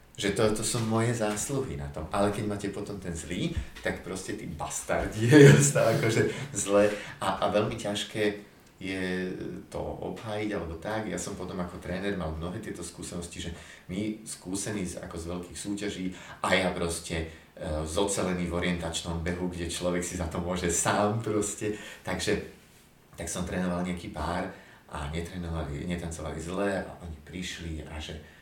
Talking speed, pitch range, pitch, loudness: 165 wpm, 85-105 Hz, 90 Hz, -29 LUFS